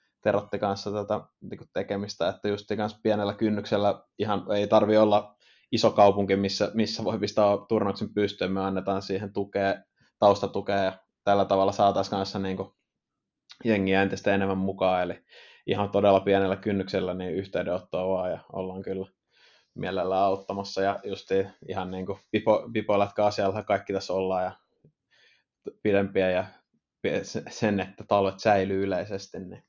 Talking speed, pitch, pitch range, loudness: 140 wpm, 100 Hz, 95-105 Hz, -27 LUFS